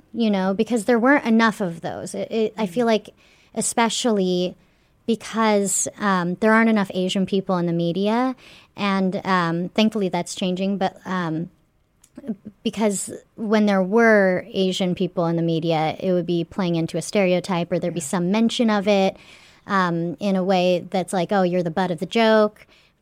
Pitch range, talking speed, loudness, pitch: 180-220 Hz, 175 wpm, -21 LUFS, 195 Hz